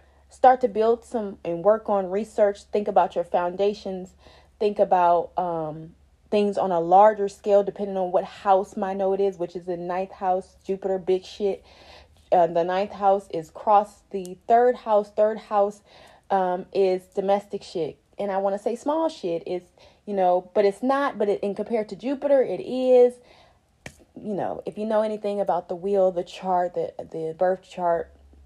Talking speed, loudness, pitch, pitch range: 180 wpm, -24 LUFS, 195 Hz, 180-210 Hz